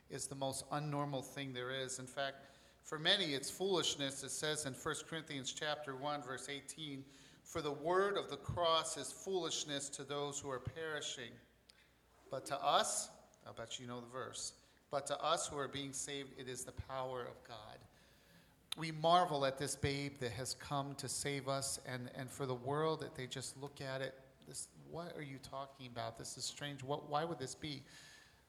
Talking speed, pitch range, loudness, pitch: 195 wpm, 130-150 Hz, -41 LUFS, 140 Hz